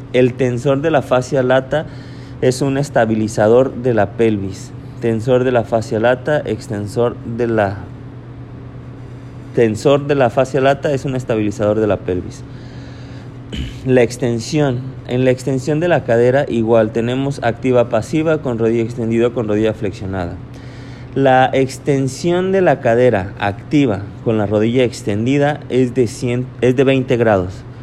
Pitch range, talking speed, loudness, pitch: 115-130 Hz, 140 wpm, -16 LUFS, 125 Hz